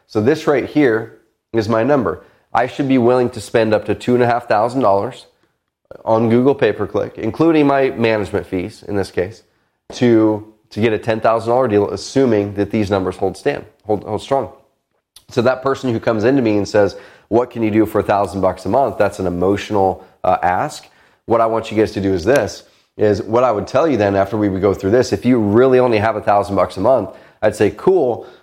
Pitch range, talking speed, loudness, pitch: 100-125 Hz, 215 wpm, -16 LUFS, 110 Hz